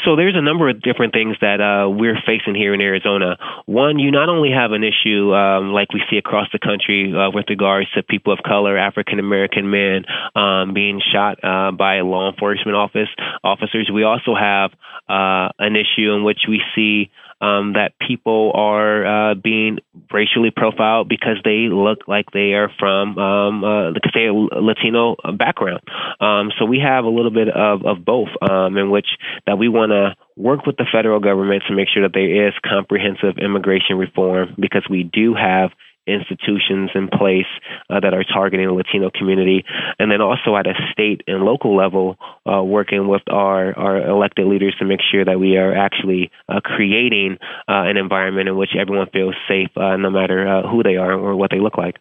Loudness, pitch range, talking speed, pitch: -16 LUFS, 95-105 Hz, 195 wpm, 100 Hz